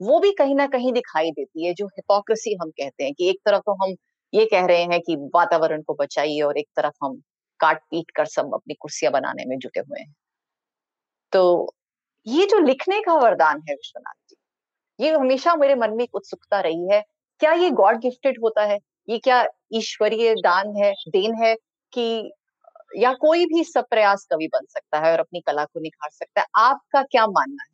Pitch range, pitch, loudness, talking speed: 175-280 Hz, 220 Hz, -21 LUFS, 195 wpm